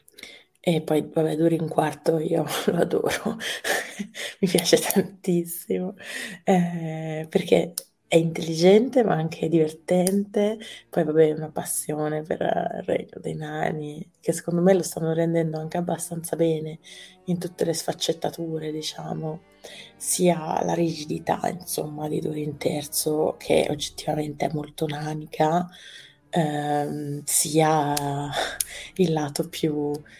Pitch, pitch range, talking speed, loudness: 160 Hz, 155-180 Hz, 120 wpm, -25 LUFS